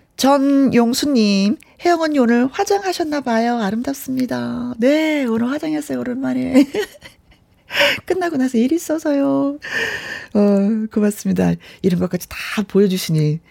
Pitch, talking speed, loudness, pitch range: 255 Hz, 280 characters per minute, -18 LUFS, 215-300 Hz